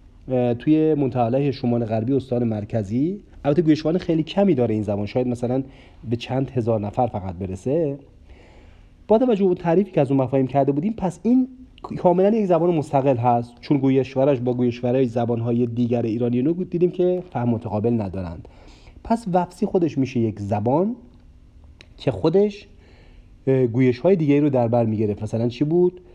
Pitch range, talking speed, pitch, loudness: 115-165 Hz, 160 wpm, 130 Hz, -21 LUFS